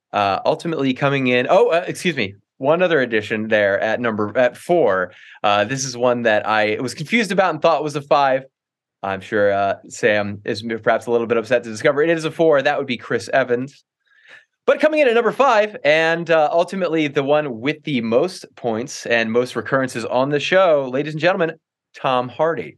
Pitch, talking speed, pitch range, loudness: 135 Hz, 205 wpm, 120-165 Hz, -18 LUFS